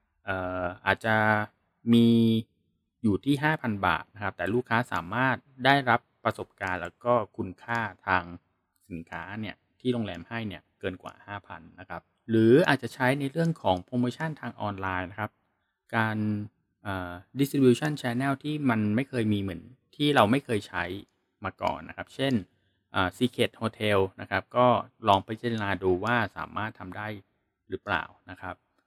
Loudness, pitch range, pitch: -28 LUFS, 95-120 Hz, 110 Hz